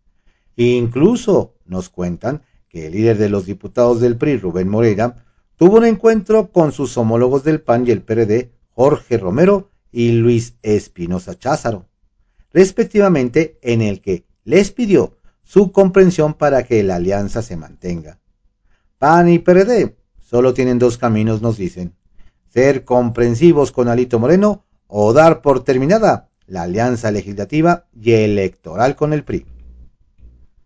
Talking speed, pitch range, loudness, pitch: 135 wpm, 100-155 Hz, -15 LUFS, 120 Hz